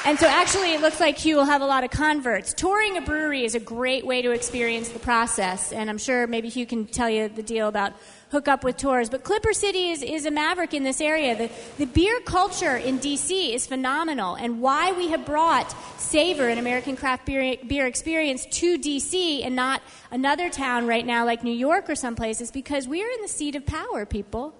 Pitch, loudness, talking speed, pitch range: 265 Hz, -24 LUFS, 225 wpm, 235-315 Hz